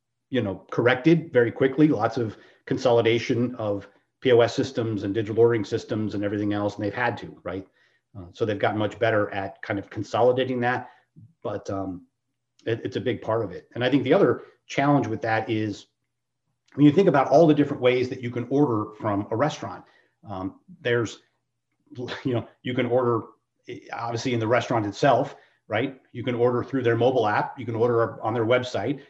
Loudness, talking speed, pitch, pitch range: -24 LUFS, 190 wpm, 120 Hz, 105-130 Hz